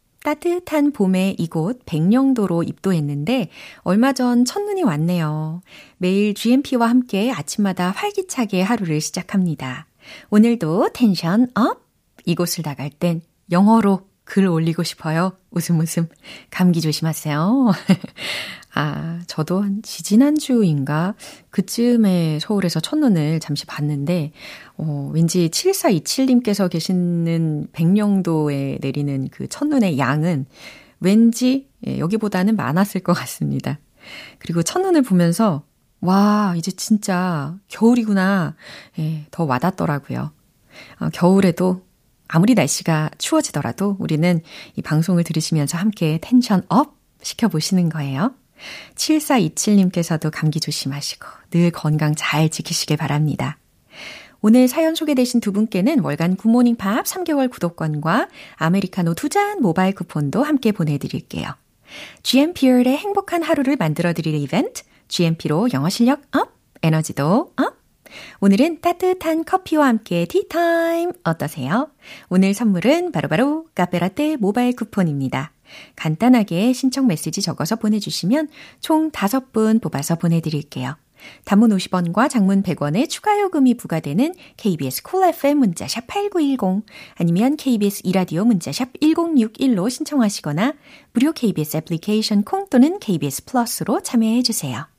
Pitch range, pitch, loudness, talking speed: 165-250 Hz, 195 Hz, -19 LUFS, 290 characters per minute